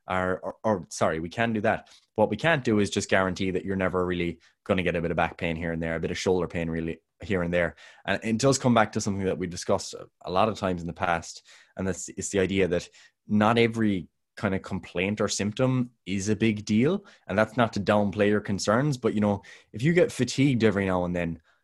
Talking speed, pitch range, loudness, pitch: 250 wpm, 90-110 Hz, -26 LUFS, 100 Hz